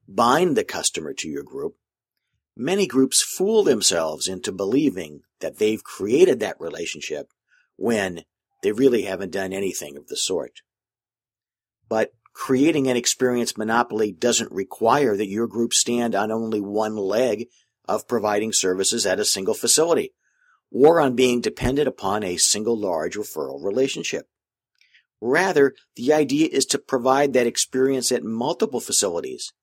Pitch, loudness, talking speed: 130 Hz, -21 LUFS, 140 wpm